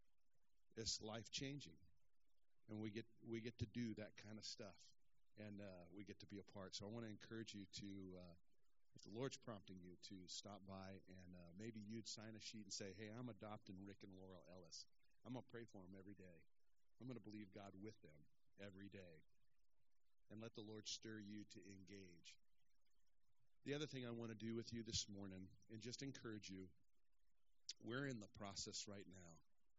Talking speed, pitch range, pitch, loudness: 200 wpm, 95-115 Hz, 105 Hz, -55 LUFS